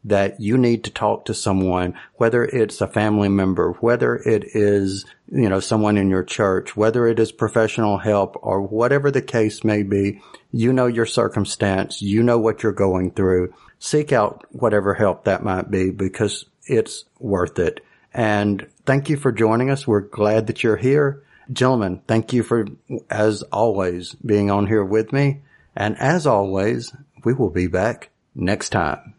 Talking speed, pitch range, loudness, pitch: 175 wpm, 100-120 Hz, -20 LUFS, 105 Hz